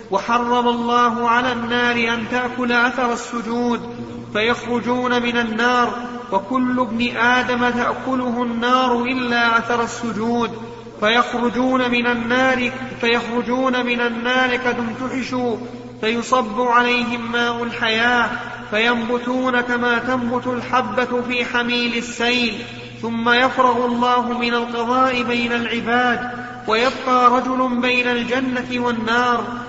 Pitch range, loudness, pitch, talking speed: 235-245 Hz, -18 LUFS, 240 Hz, 95 wpm